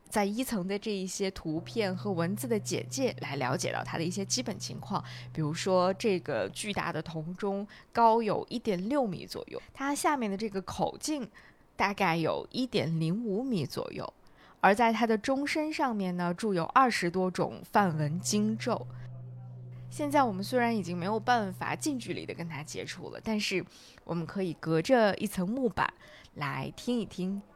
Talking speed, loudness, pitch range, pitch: 260 characters per minute, -31 LUFS, 170-230 Hz, 195 Hz